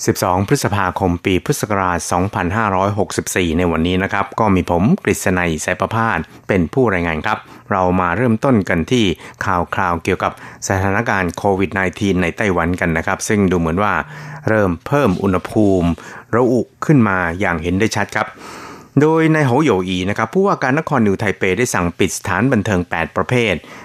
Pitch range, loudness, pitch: 90-110 Hz, -17 LUFS, 95 Hz